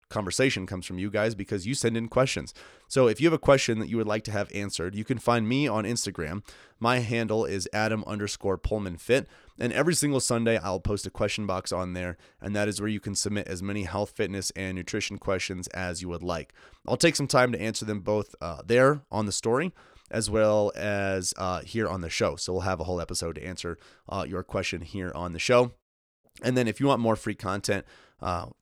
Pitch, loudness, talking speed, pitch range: 105 Hz, -28 LUFS, 230 wpm, 95-115 Hz